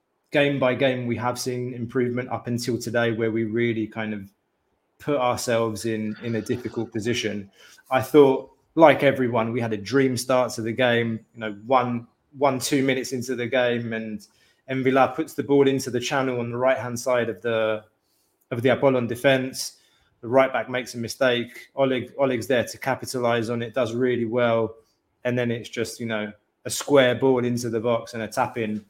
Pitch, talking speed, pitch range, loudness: 120 Hz, 195 wpm, 115-130 Hz, -23 LUFS